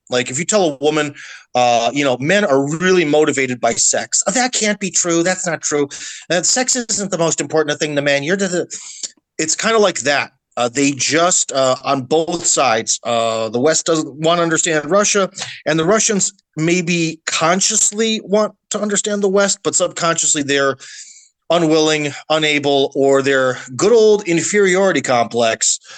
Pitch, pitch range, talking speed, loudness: 160 Hz, 140-190 Hz, 175 wpm, -15 LUFS